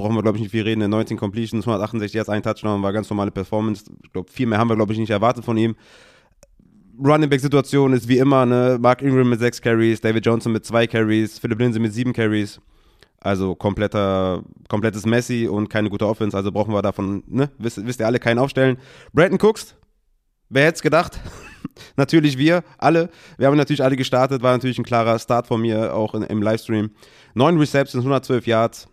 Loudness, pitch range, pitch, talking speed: -19 LUFS, 110-130 Hz, 115 Hz, 205 wpm